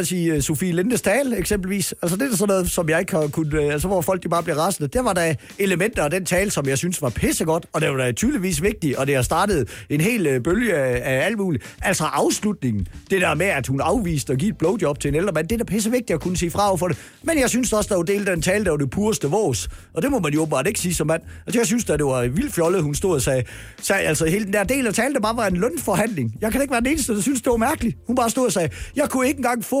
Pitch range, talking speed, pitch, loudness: 155-215 Hz, 300 wpm, 180 Hz, -21 LUFS